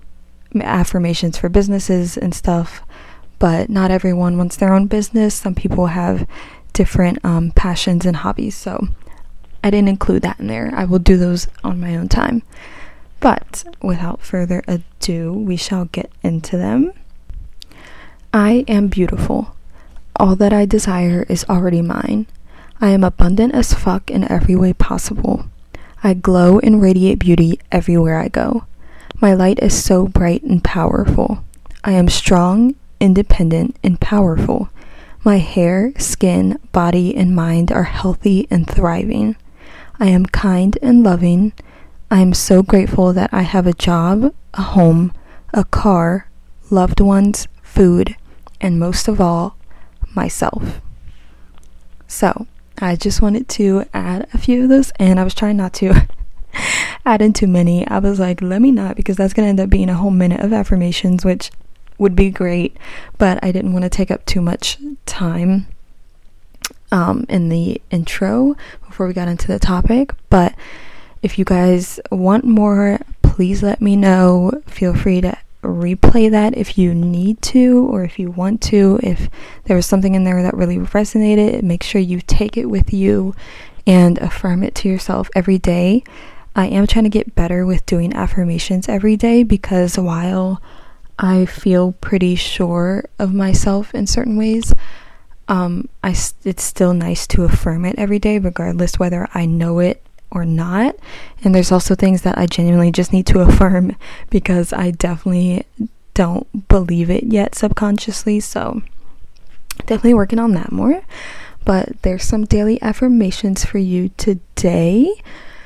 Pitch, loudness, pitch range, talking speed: 190 Hz, -15 LUFS, 180-210 Hz, 155 wpm